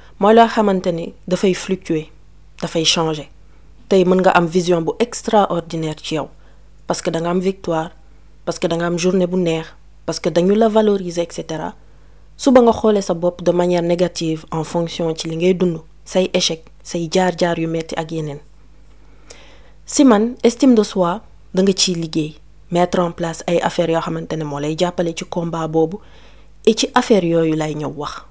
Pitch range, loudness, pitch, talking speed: 165-190 Hz, -17 LUFS, 175 Hz, 140 wpm